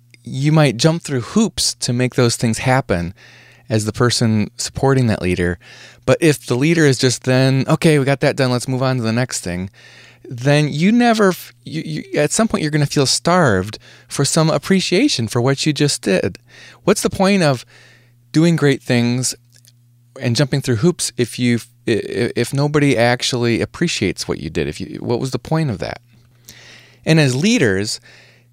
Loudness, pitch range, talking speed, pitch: -17 LUFS, 120-150 Hz, 185 wpm, 130 Hz